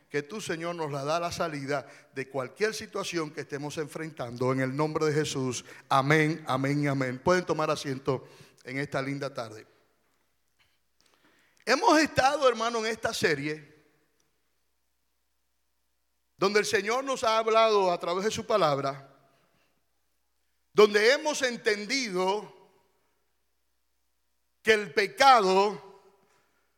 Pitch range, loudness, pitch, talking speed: 130-200 Hz, -27 LUFS, 155 Hz, 120 wpm